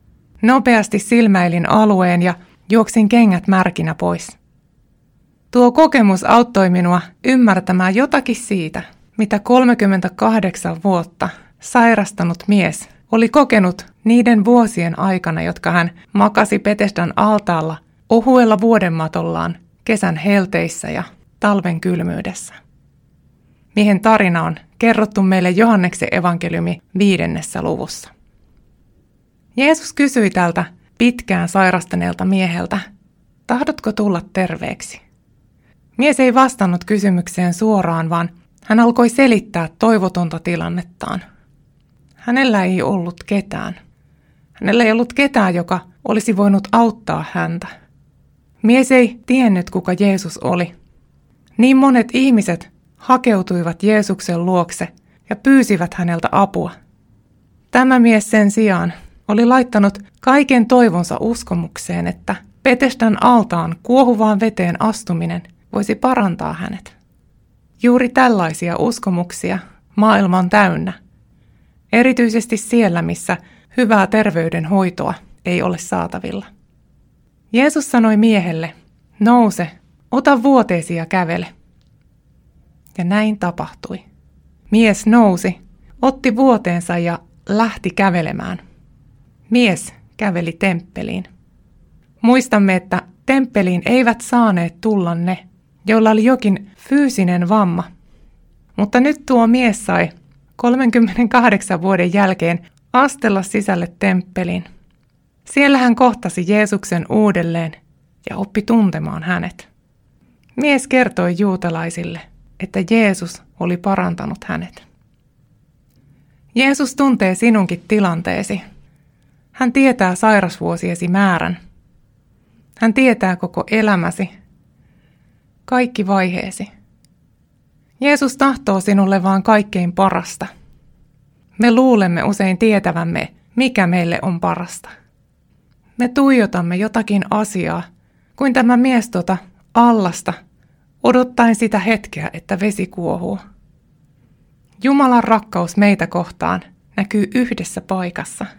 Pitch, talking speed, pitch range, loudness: 195 Hz, 95 wpm, 175-230 Hz, -15 LUFS